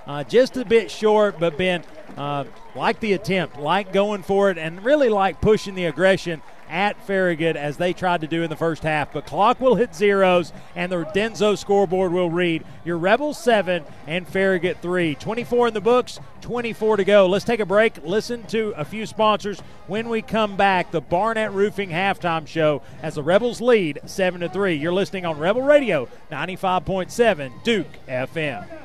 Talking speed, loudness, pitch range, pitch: 190 wpm, -21 LUFS, 165-215 Hz, 190 Hz